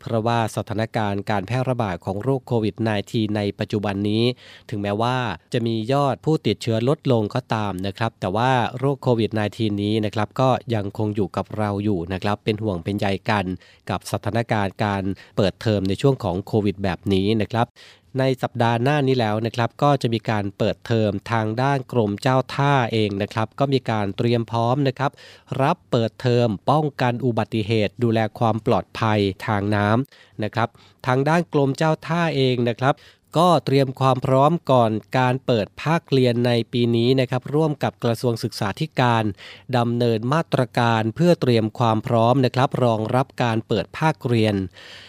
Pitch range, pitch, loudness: 105-130 Hz, 115 Hz, -22 LUFS